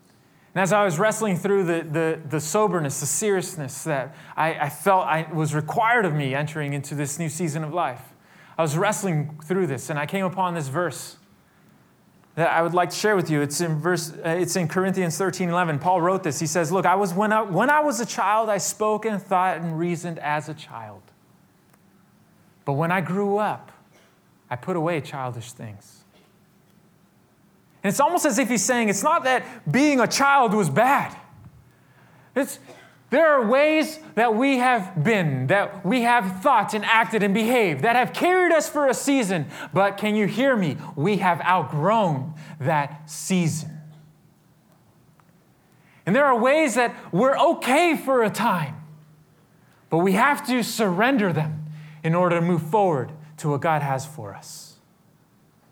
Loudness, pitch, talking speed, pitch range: -22 LUFS, 180 Hz, 175 wpm, 155-215 Hz